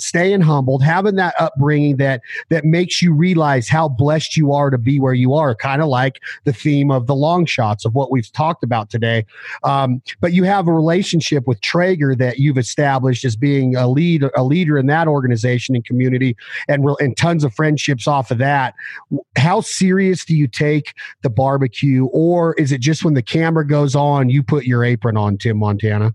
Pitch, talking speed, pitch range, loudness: 140 Hz, 200 wpm, 130-160 Hz, -16 LUFS